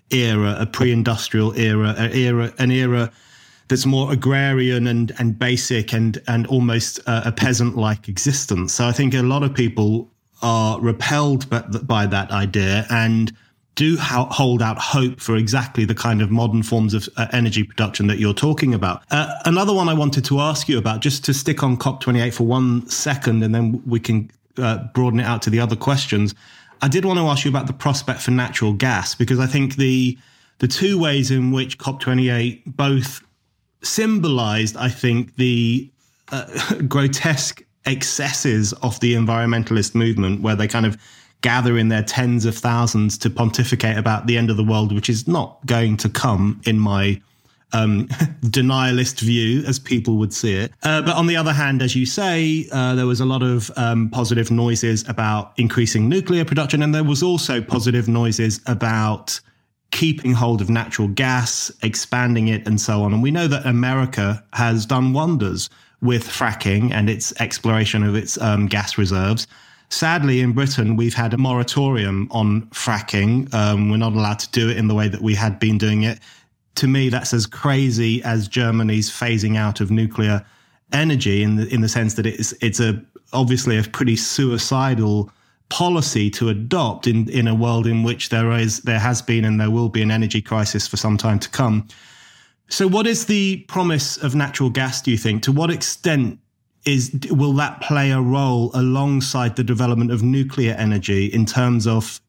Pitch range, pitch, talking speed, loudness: 110-130 Hz, 120 Hz, 185 wpm, -19 LUFS